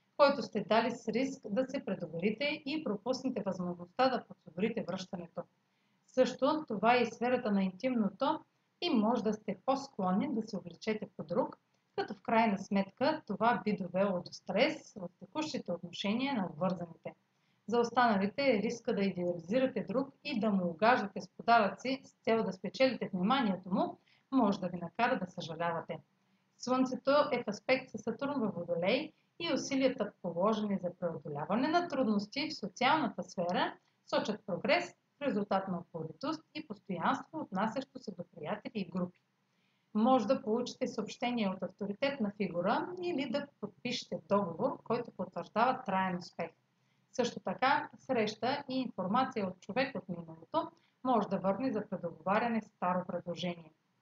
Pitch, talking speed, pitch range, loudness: 220 Hz, 150 wpm, 185-260 Hz, -34 LUFS